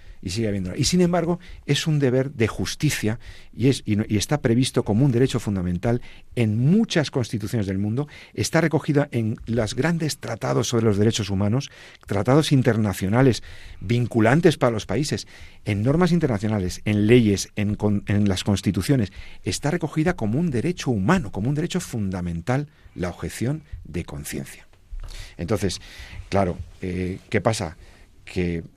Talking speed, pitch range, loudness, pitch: 150 wpm, 95-135 Hz, -23 LUFS, 110 Hz